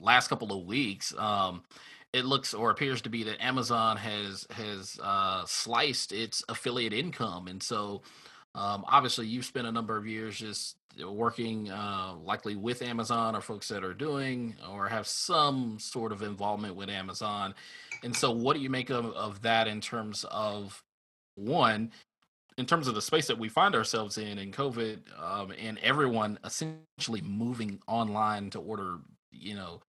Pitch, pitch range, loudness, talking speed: 110 Hz, 105-120 Hz, -31 LUFS, 170 wpm